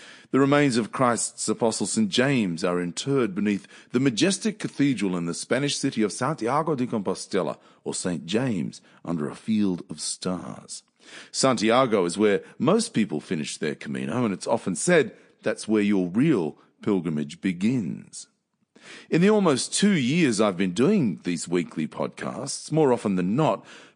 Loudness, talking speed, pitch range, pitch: -25 LUFS, 155 wpm, 100-155 Hz, 120 Hz